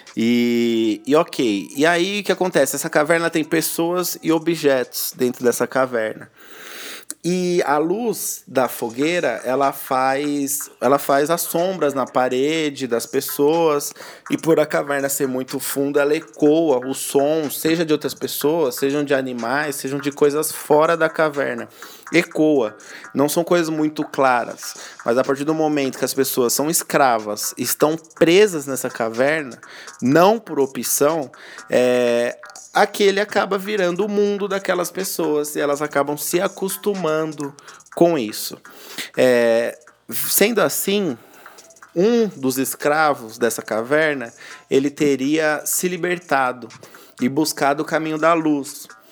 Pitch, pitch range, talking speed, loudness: 145 Hz, 135-165 Hz, 135 wpm, -19 LUFS